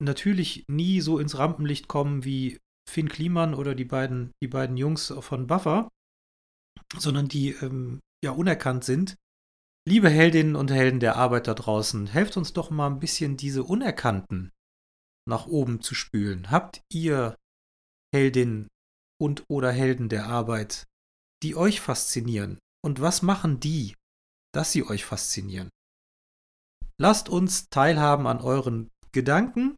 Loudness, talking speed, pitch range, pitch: -25 LUFS, 135 wpm, 110-155 Hz, 135 Hz